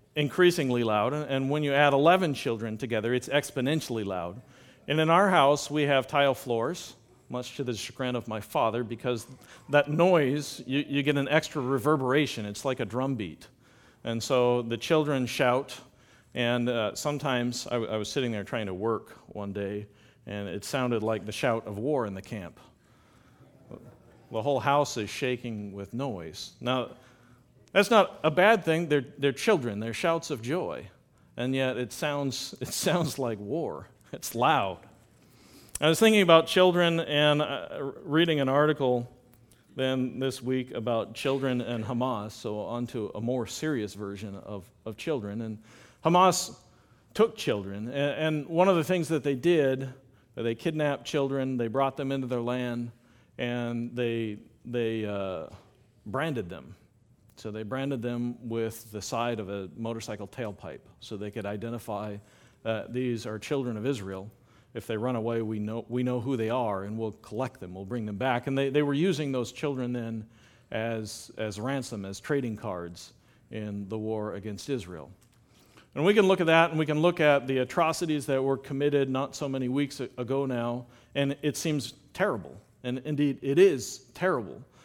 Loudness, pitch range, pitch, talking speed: -28 LUFS, 110-145 Hz, 125 Hz, 175 wpm